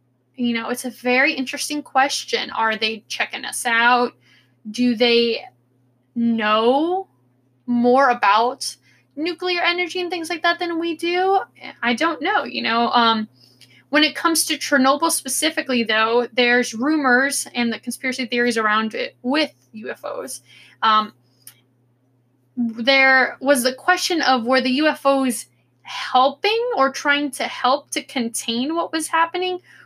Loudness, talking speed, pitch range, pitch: -19 LUFS, 135 wpm, 225-305 Hz, 255 Hz